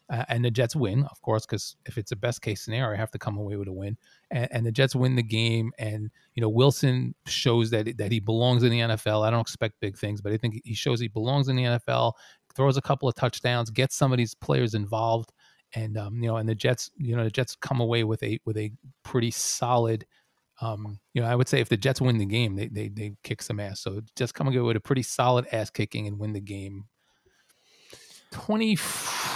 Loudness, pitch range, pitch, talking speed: -27 LUFS, 110-125 Hz, 115 Hz, 245 wpm